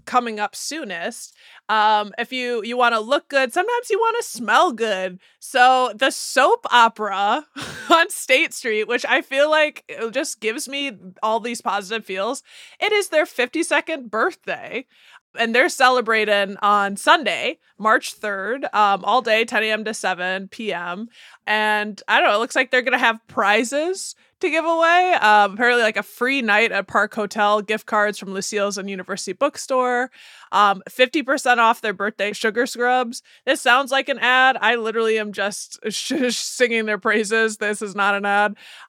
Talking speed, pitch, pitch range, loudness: 170 wpm, 230 Hz, 210-265 Hz, -19 LUFS